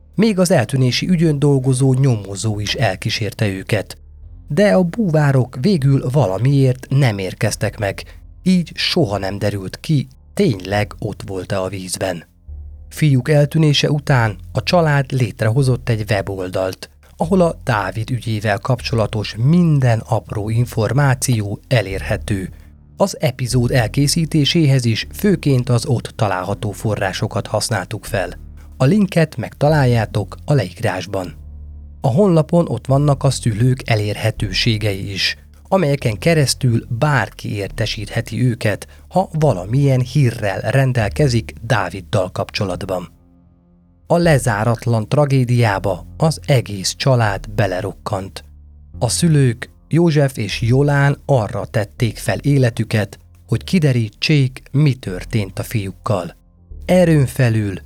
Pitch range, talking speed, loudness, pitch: 95-140 Hz, 110 wpm, -17 LUFS, 115 Hz